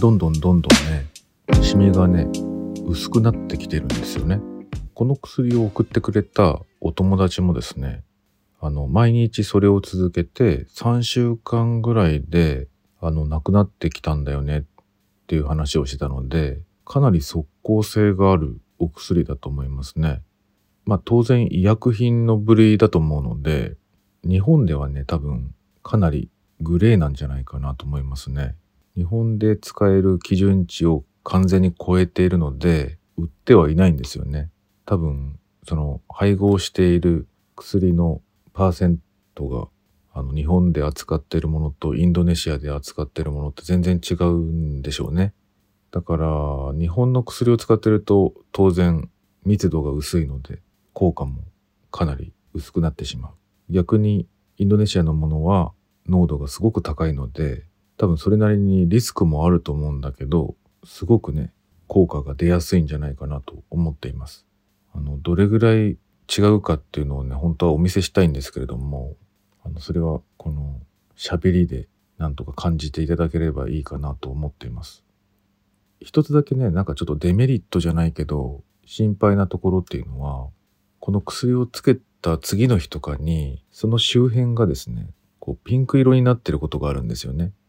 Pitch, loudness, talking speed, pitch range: 85 Hz, -20 LUFS, 320 characters per minute, 75-100 Hz